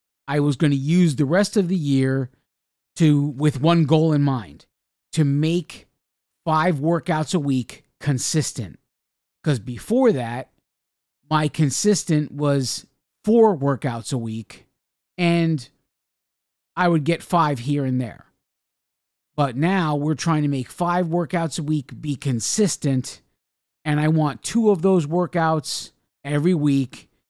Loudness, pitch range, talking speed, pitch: -21 LUFS, 140-170 Hz, 135 wpm, 155 Hz